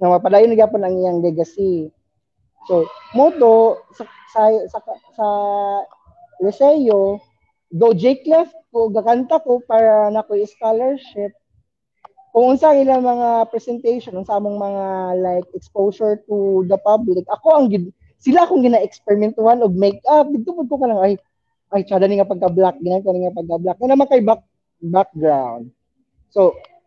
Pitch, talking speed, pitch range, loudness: 215 Hz, 140 wpm, 190-255 Hz, -16 LUFS